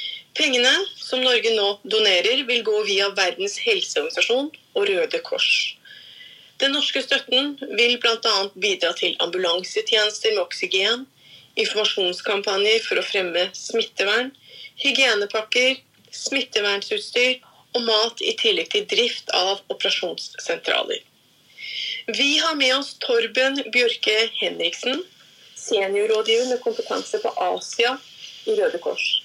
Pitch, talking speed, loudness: 270 Hz, 110 wpm, -21 LUFS